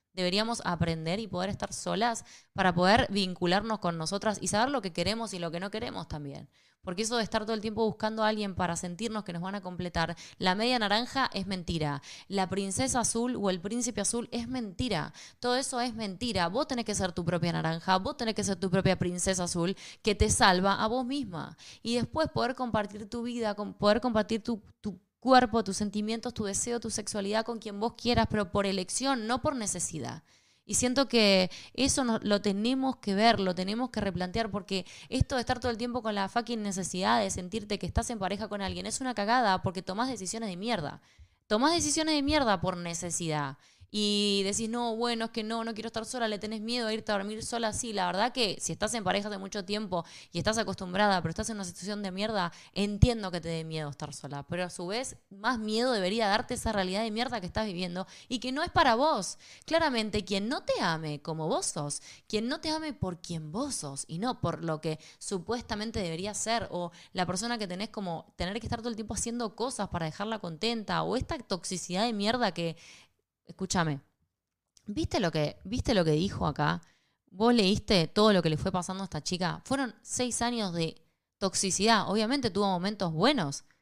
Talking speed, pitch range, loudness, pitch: 210 wpm, 180-230 Hz, -30 LUFS, 205 Hz